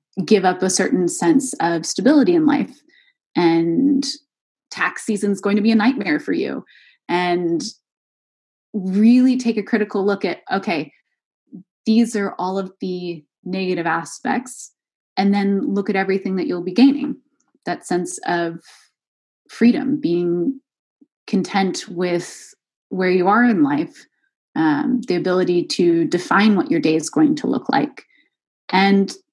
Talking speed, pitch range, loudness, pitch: 145 wpm, 180-270 Hz, -19 LUFS, 200 Hz